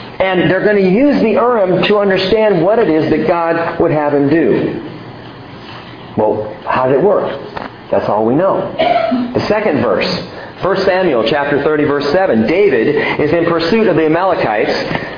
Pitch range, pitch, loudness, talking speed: 160-210 Hz, 185 Hz, -13 LUFS, 170 wpm